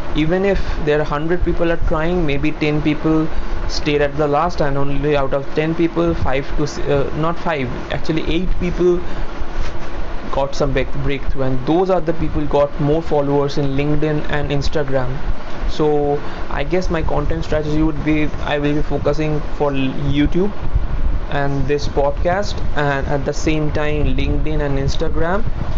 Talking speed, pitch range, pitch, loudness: 160 wpm, 140-155 Hz, 150 Hz, -19 LUFS